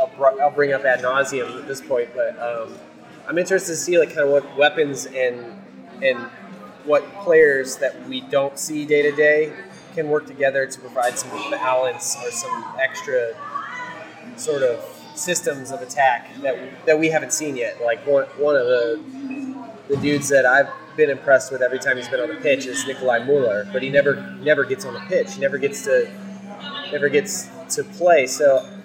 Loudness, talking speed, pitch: -20 LUFS, 190 wpm, 150 Hz